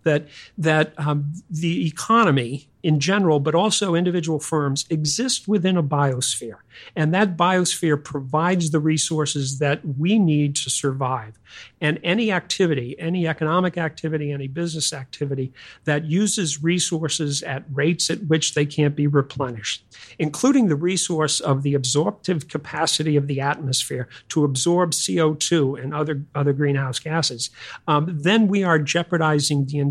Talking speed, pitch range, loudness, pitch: 140 wpm, 145-170 Hz, -21 LUFS, 155 Hz